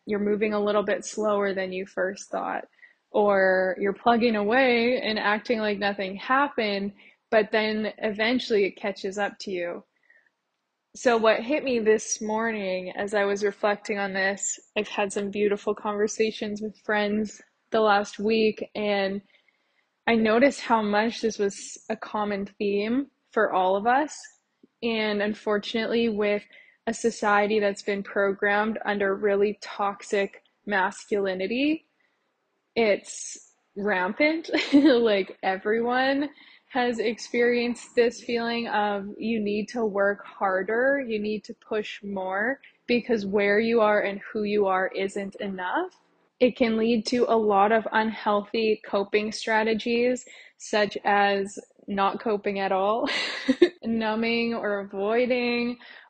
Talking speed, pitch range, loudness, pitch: 130 wpm, 200-235 Hz, -25 LUFS, 215 Hz